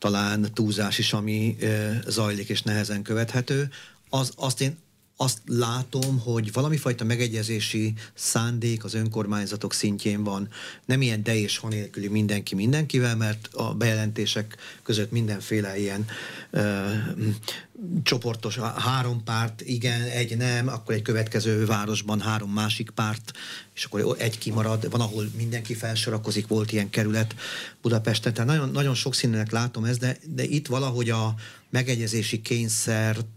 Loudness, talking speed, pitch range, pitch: -26 LUFS, 140 wpm, 105-125 Hz, 115 Hz